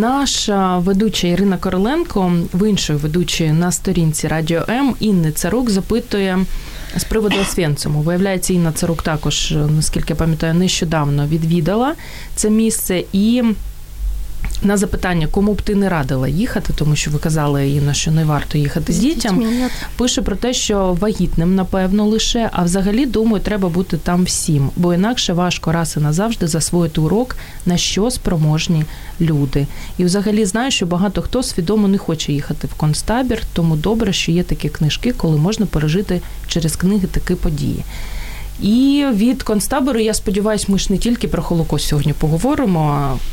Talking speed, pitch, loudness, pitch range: 155 wpm, 180 Hz, -17 LUFS, 160-210 Hz